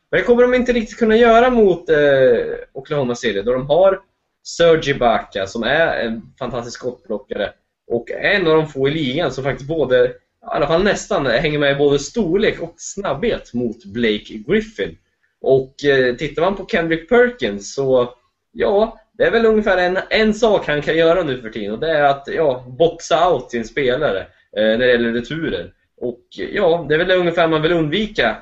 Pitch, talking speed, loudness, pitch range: 160 Hz, 190 wpm, -17 LUFS, 130-205 Hz